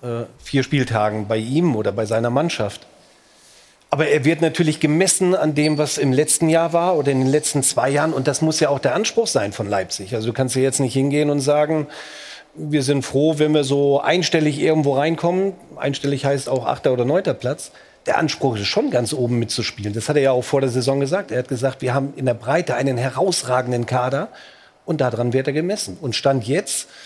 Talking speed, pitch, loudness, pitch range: 215 wpm, 140 Hz, -19 LUFS, 125-155 Hz